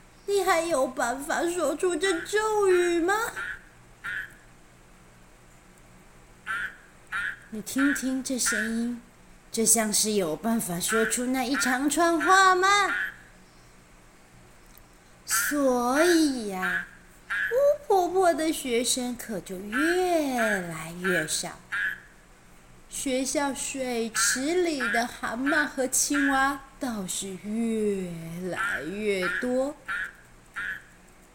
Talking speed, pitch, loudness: 120 characters per minute, 230 Hz, -26 LUFS